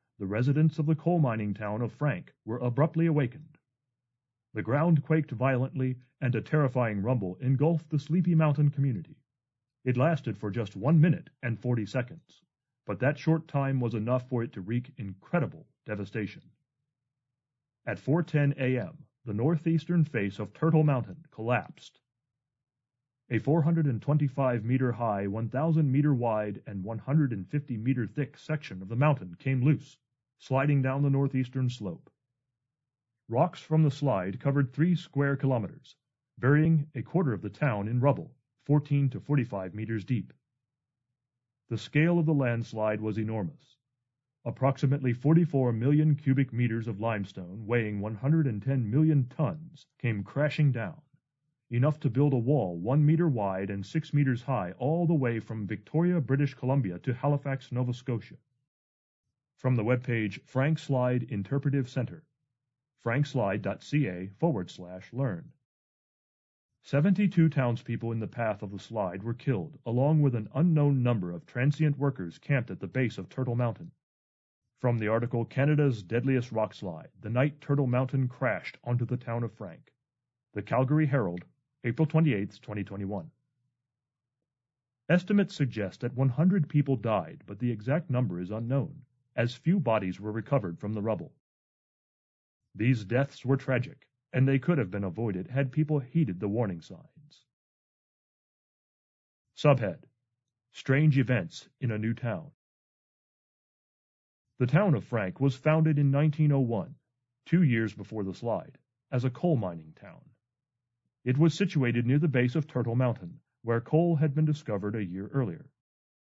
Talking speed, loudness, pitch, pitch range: 145 wpm, -29 LUFS, 130 Hz, 115-145 Hz